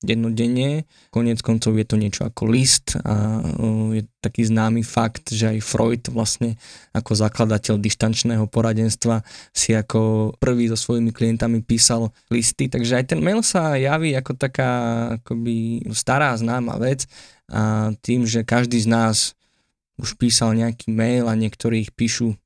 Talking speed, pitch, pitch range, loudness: 145 wpm, 115 Hz, 110-120 Hz, -20 LUFS